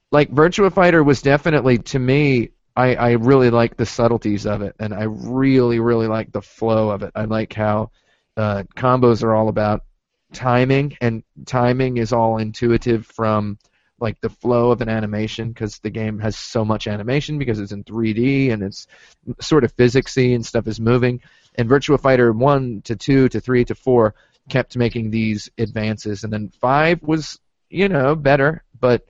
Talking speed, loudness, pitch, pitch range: 180 wpm, -18 LUFS, 120 Hz, 110-130 Hz